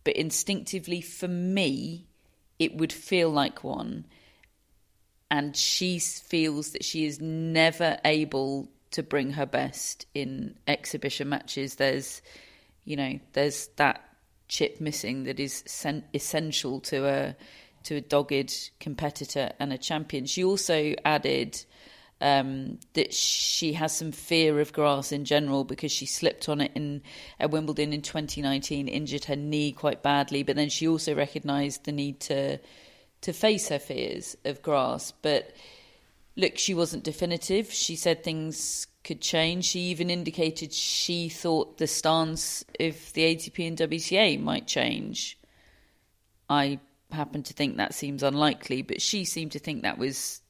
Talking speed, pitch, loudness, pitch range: 145 wpm, 150 Hz, -28 LUFS, 140-165 Hz